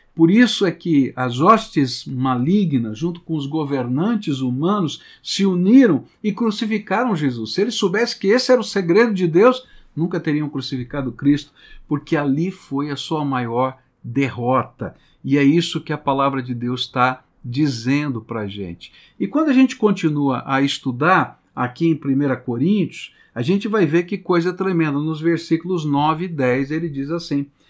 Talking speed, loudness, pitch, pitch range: 165 wpm, -19 LUFS, 150 Hz, 135-185 Hz